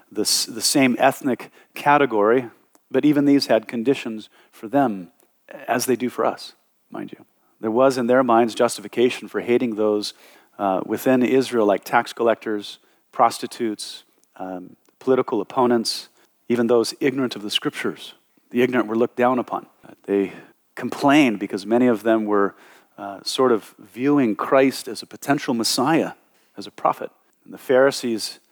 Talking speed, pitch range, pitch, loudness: 155 wpm, 110-130 Hz, 120 Hz, -21 LUFS